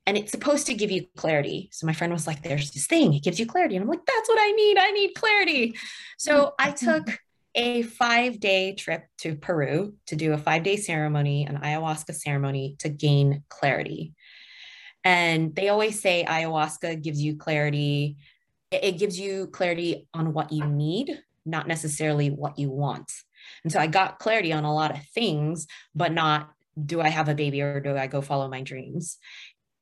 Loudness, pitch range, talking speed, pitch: -25 LUFS, 150-195 Hz, 190 wpm, 160 Hz